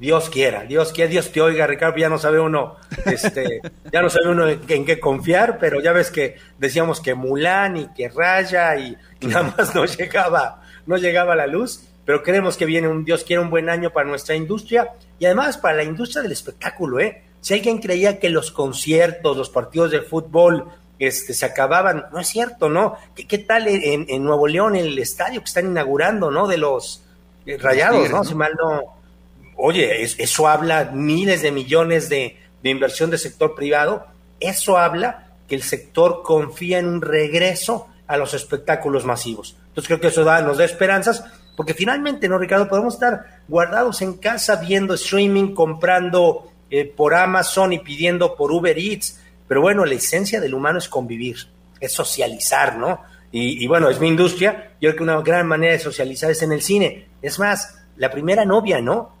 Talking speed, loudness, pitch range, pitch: 195 wpm, -18 LUFS, 150-190 Hz, 165 Hz